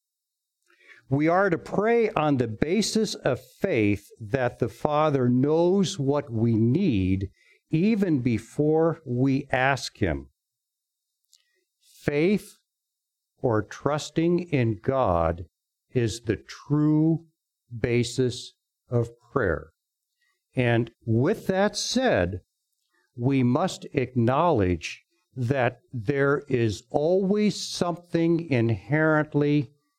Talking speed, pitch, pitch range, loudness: 90 wpm, 140 Hz, 115-170 Hz, -25 LUFS